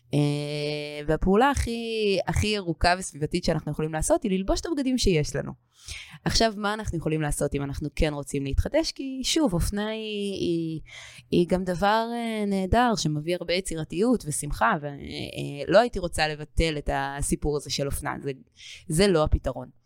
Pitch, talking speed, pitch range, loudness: 170 Hz, 150 wpm, 150-210 Hz, -26 LUFS